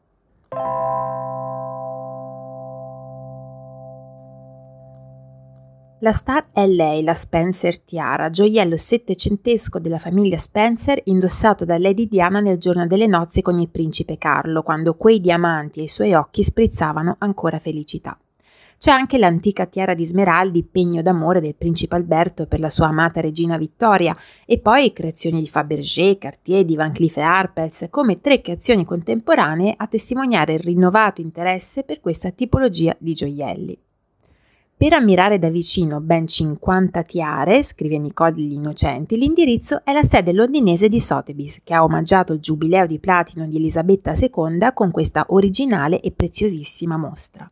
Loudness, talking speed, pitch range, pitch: -17 LUFS, 140 wpm, 155-195 Hz, 170 Hz